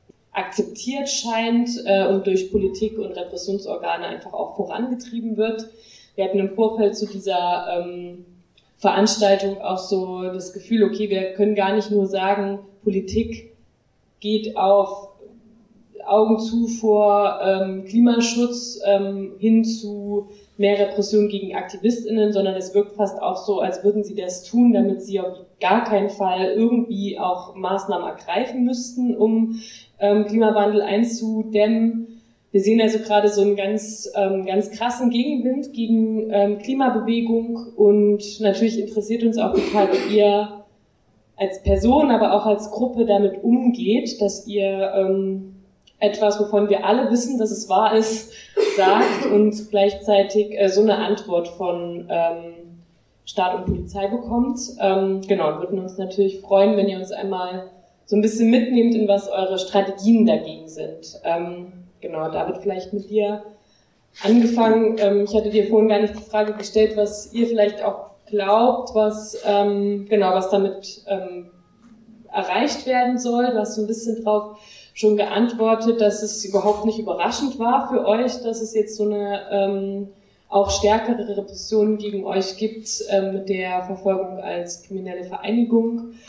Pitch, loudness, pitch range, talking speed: 205 Hz, -20 LUFS, 195-225 Hz, 145 wpm